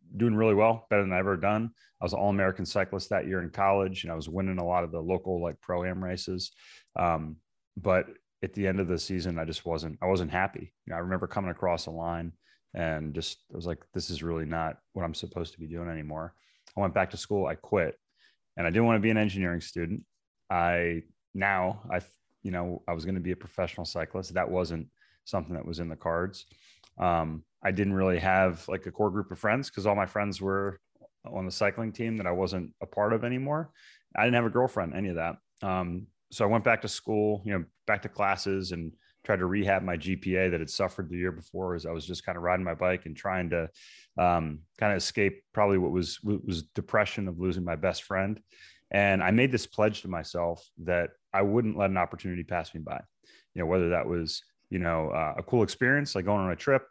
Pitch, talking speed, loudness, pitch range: 90 Hz, 235 wpm, -30 LUFS, 85-100 Hz